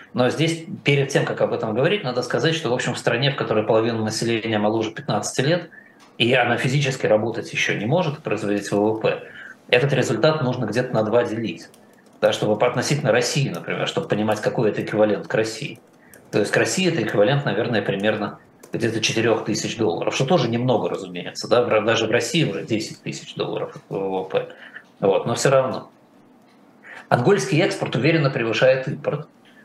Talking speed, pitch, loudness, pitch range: 170 wpm, 125 Hz, -21 LUFS, 110-150 Hz